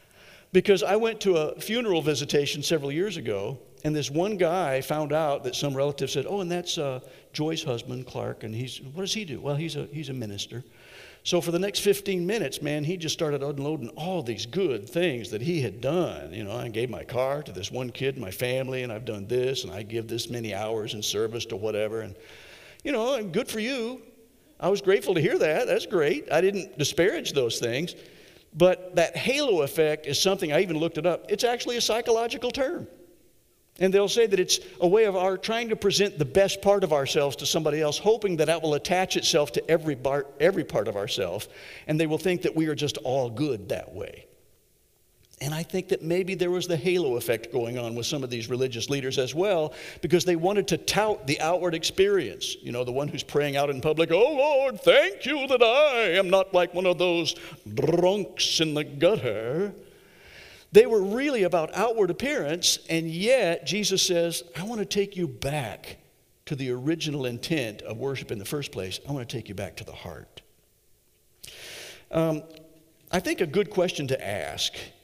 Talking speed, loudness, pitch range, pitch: 210 wpm, -26 LUFS, 135-195 Hz, 160 Hz